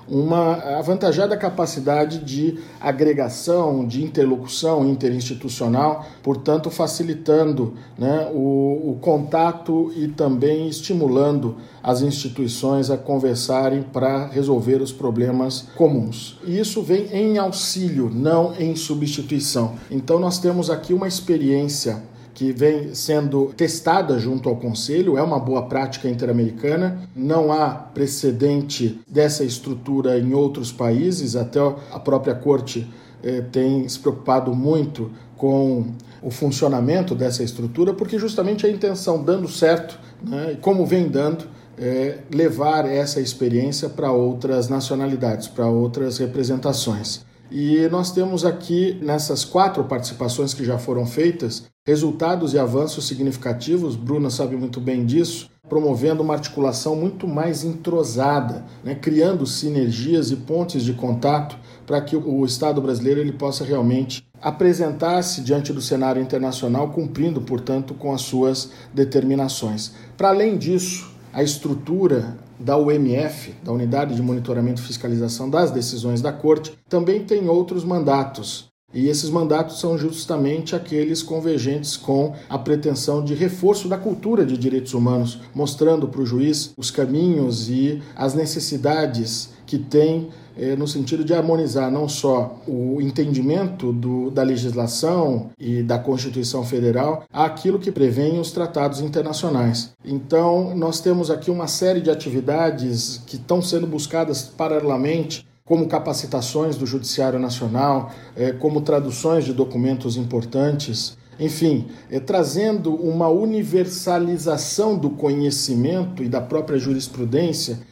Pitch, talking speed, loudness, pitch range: 140 Hz, 130 wpm, -21 LUFS, 130-160 Hz